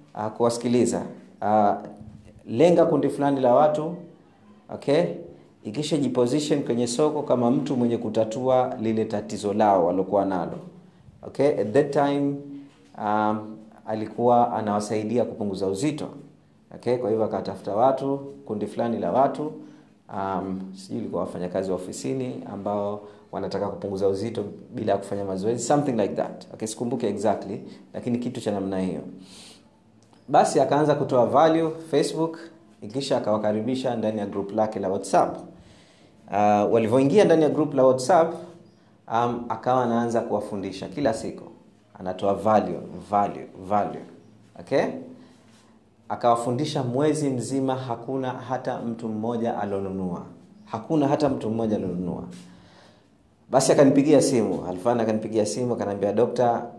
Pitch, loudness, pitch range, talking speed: 115 Hz, -24 LUFS, 105-135 Hz, 120 wpm